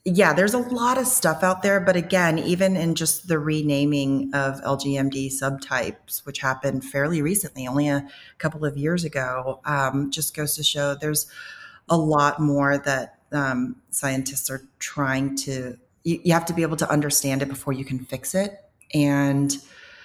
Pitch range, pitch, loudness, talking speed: 135-165 Hz, 145 Hz, -23 LUFS, 175 wpm